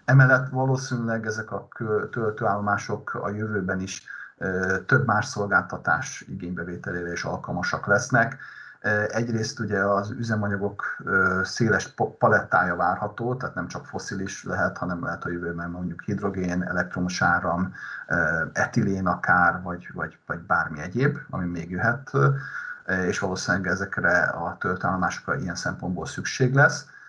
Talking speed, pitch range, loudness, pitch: 120 wpm, 90-115 Hz, -25 LUFS, 100 Hz